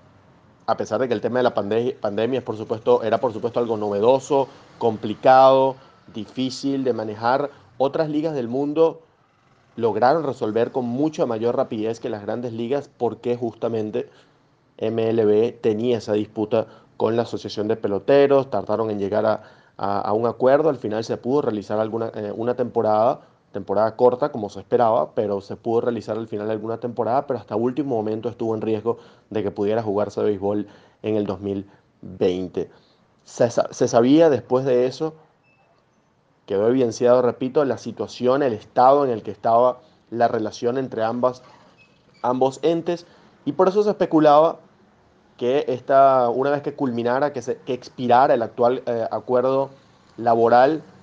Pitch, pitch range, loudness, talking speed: 120 Hz, 110-135 Hz, -21 LUFS, 160 wpm